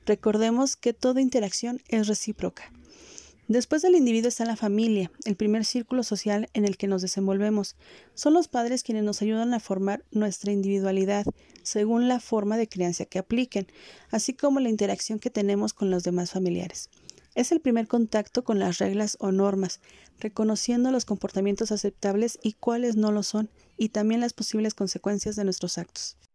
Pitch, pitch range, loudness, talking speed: 215 Hz, 200-235 Hz, -26 LUFS, 170 wpm